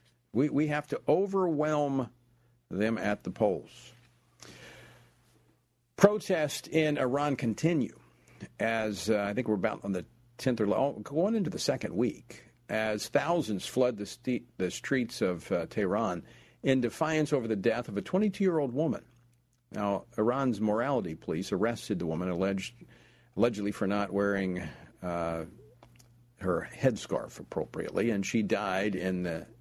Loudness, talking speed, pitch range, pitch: -31 LUFS, 140 wpm, 100-140 Hz, 115 Hz